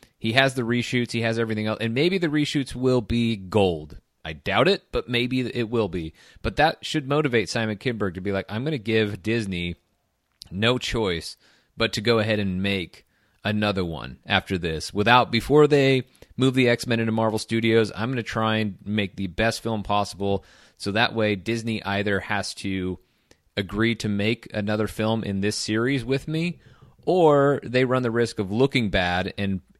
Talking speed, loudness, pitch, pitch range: 185 wpm, -24 LUFS, 110 Hz, 100-125 Hz